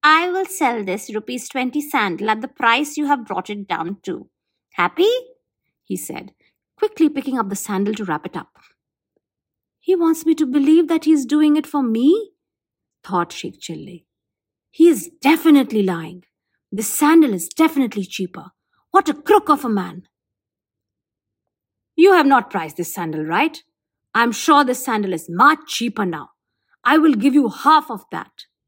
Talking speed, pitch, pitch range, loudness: 170 wpm, 250 Hz, 185-310 Hz, -18 LUFS